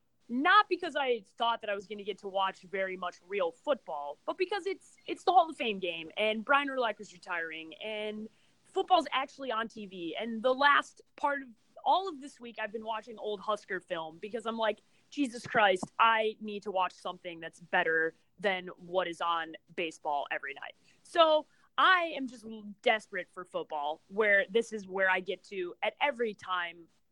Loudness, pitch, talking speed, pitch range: -32 LUFS, 215 Hz, 190 wpm, 185-260 Hz